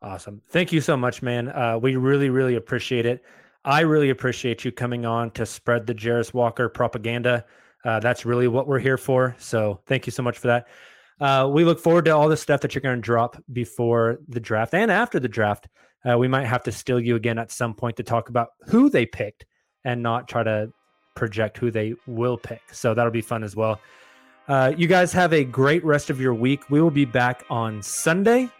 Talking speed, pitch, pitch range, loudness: 220 wpm, 125 Hz, 115-135 Hz, -22 LUFS